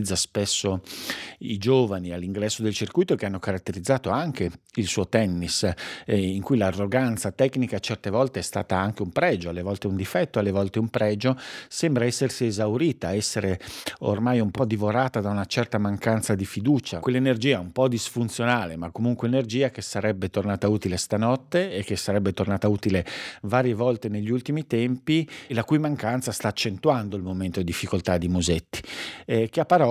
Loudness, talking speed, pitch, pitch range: -25 LUFS, 170 wpm, 105 Hz, 100-125 Hz